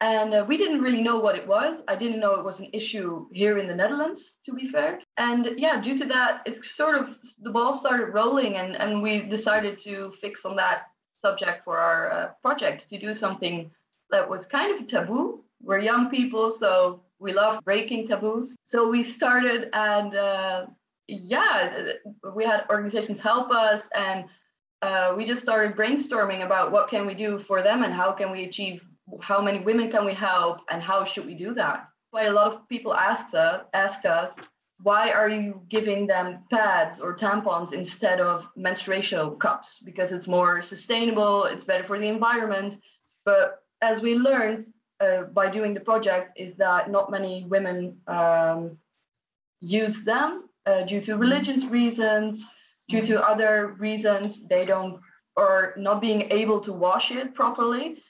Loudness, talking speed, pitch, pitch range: -24 LUFS, 180 wpm, 210 Hz, 195-235 Hz